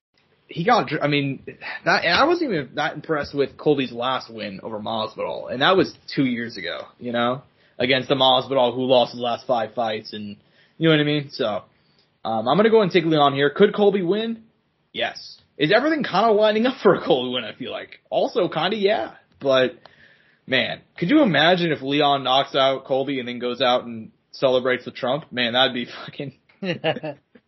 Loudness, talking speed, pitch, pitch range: -21 LUFS, 205 wpm, 135 Hz, 125-160 Hz